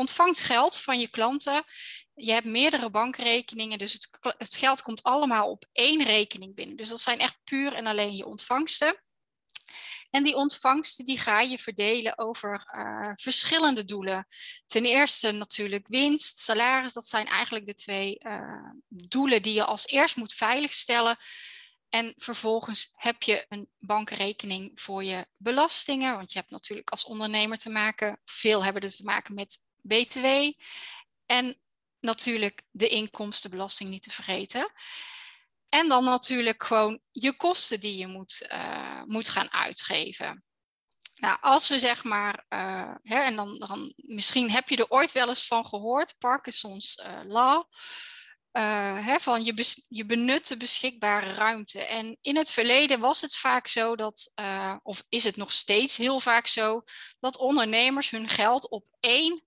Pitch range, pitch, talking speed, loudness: 215-270 Hz, 235 Hz, 155 wpm, -25 LUFS